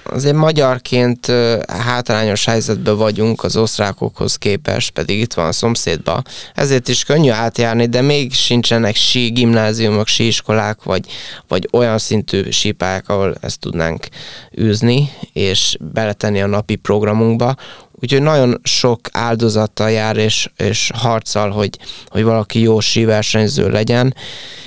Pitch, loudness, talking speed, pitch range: 110 Hz, -15 LUFS, 125 wpm, 105-120 Hz